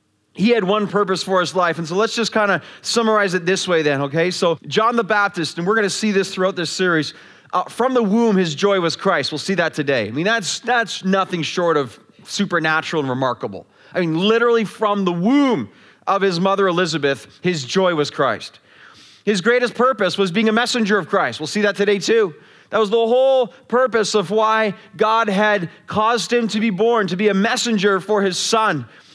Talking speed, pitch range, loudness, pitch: 210 wpm, 175-220 Hz, -18 LUFS, 195 Hz